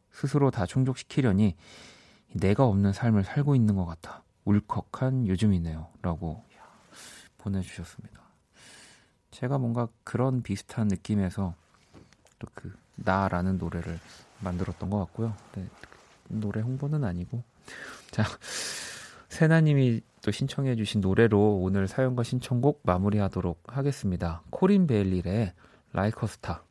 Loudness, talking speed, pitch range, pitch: -28 LUFS, 285 characters per minute, 95-125 Hz, 105 Hz